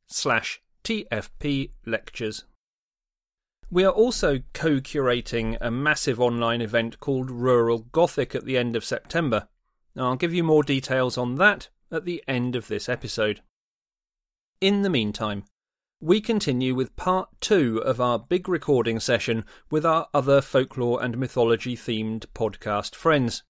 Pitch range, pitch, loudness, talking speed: 115-155 Hz, 130 Hz, -24 LUFS, 140 wpm